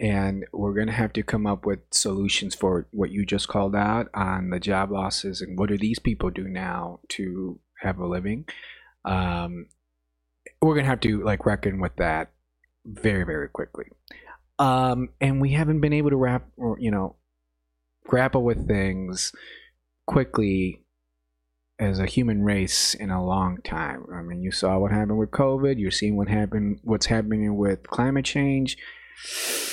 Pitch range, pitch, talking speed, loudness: 90-115 Hz, 100 Hz, 170 wpm, -25 LUFS